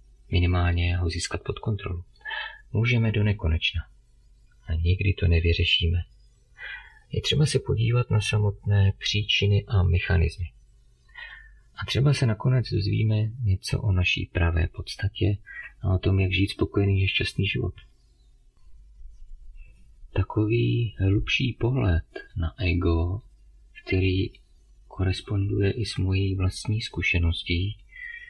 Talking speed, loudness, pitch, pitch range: 110 wpm, -25 LUFS, 95 Hz, 85-110 Hz